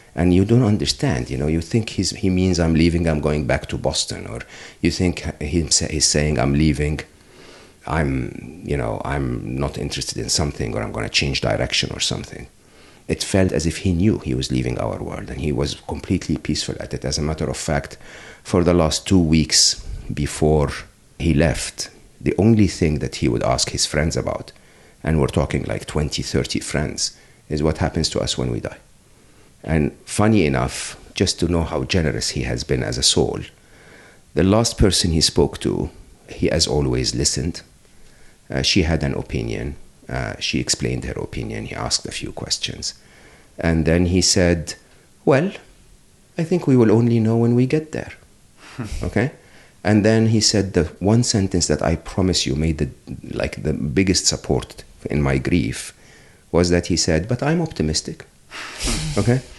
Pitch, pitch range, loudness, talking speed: 85 Hz, 75-95 Hz, -20 LUFS, 180 wpm